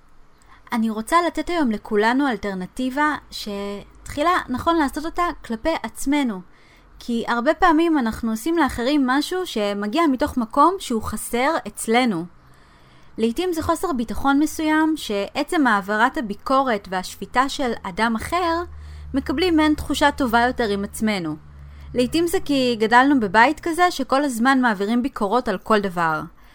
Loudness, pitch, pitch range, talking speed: -21 LUFS, 250 Hz, 210-305 Hz, 130 wpm